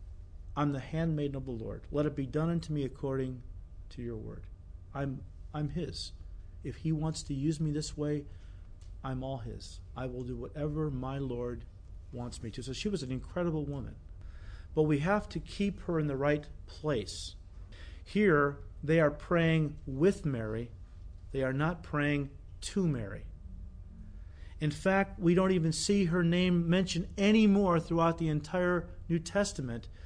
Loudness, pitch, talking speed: -32 LUFS, 135 Hz, 165 wpm